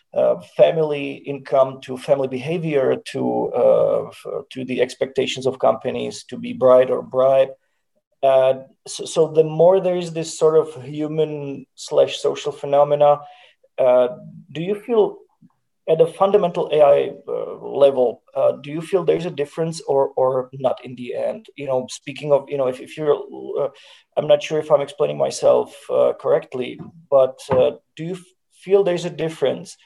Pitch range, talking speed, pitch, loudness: 135-180 Hz, 170 wpm, 155 Hz, -19 LUFS